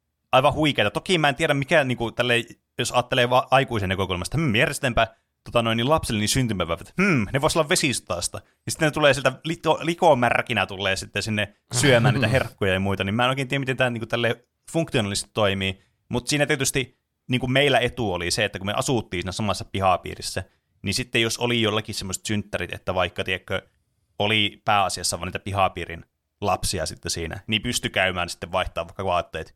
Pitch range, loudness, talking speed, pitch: 95-130 Hz, -23 LUFS, 190 wpm, 115 Hz